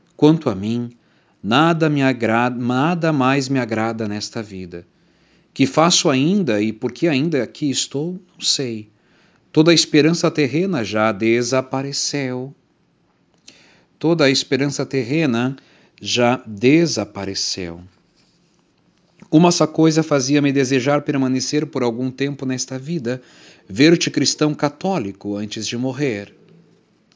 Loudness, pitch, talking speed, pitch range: -18 LUFS, 135 Hz, 115 wpm, 120-155 Hz